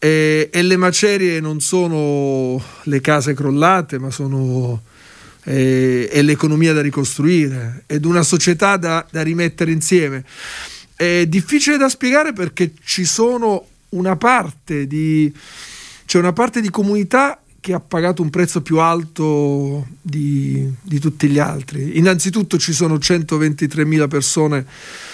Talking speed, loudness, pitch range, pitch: 130 wpm, -16 LUFS, 145-180 Hz, 155 Hz